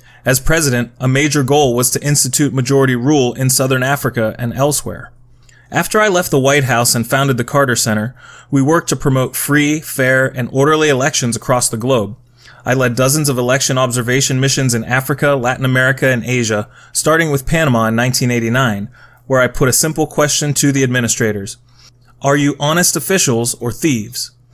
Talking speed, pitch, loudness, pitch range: 175 wpm, 130 Hz, -14 LUFS, 120-145 Hz